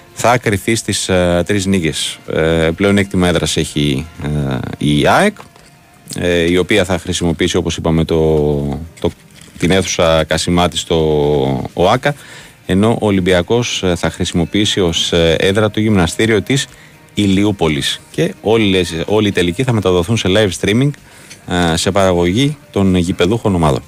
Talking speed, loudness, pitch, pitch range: 140 wpm, -14 LUFS, 90 Hz, 80-105 Hz